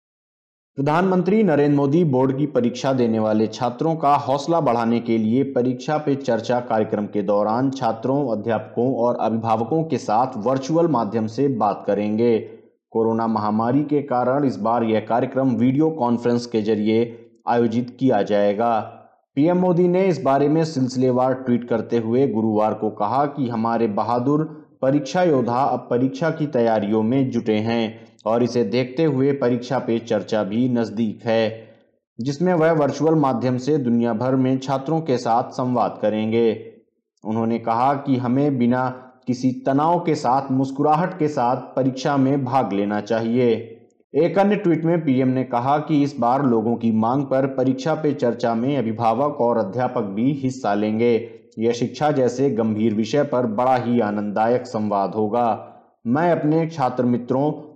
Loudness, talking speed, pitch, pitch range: -20 LUFS, 155 wpm, 125 Hz, 115-140 Hz